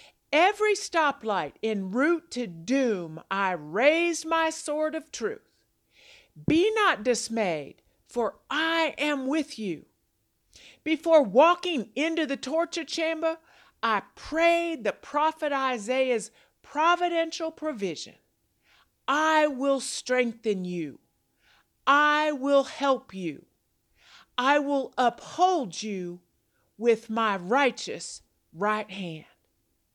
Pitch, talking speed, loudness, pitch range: 275 Hz, 100 wpm, -26 LUFS, 220-320 Hz